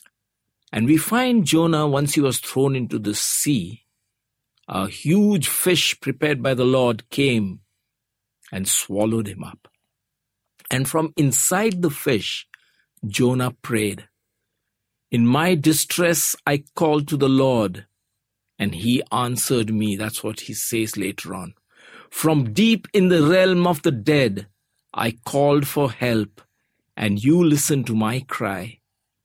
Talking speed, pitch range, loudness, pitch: 135 wpm, 110-150 Hz, -20 LUFS, 125 Hz